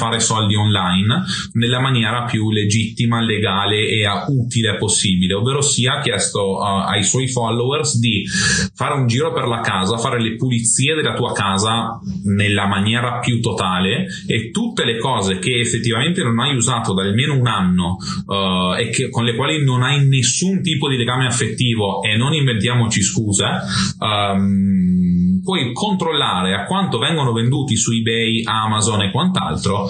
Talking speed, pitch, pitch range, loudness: 150 wpm, 115 Hz, 100-130 Hz, -17 LUFS